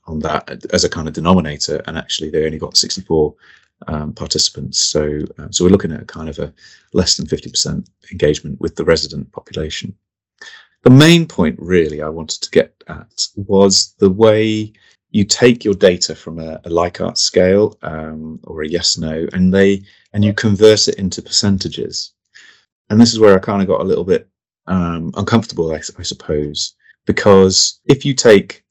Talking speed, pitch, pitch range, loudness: 180 wpm, 95 Hz, 80-105 Hz, -14 LUFS